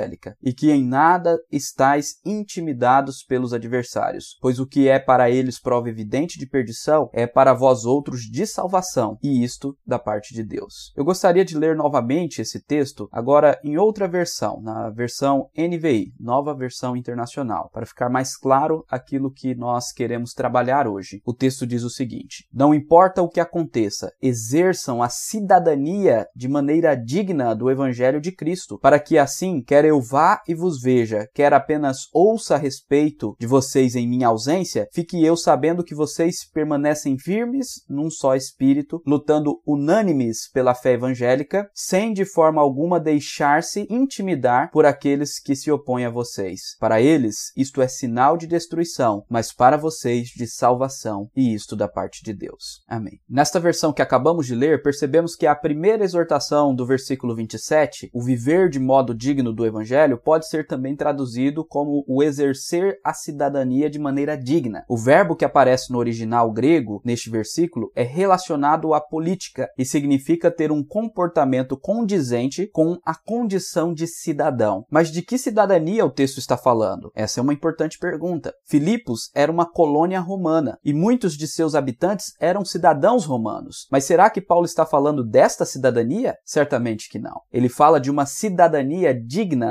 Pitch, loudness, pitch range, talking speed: 145 Hz, -20 LUFS, 125-165 Hz, 165 wpm